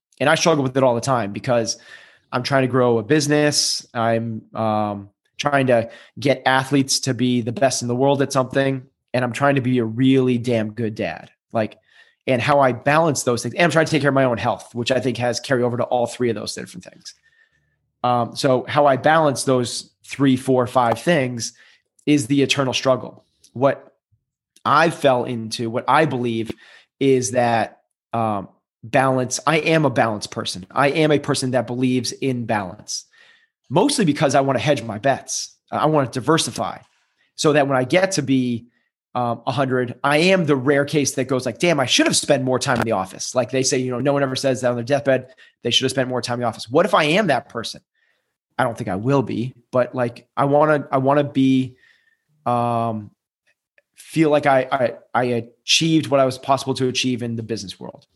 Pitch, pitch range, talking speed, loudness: 130 Hz, 120-140 Hz, 215 wpm, -19 LUFS